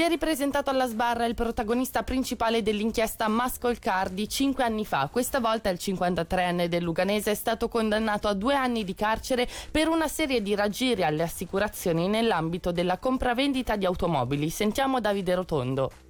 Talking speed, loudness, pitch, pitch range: 155 wpm, -27 LUFS, 220 Hz, 185-250 Hz